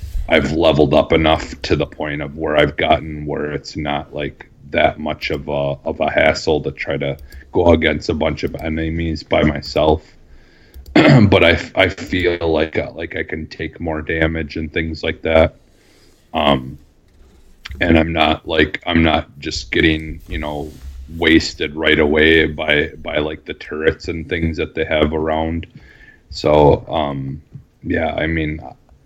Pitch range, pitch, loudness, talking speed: 75-80 Hz, 80 Hz, -17 LUFS, 160 wpm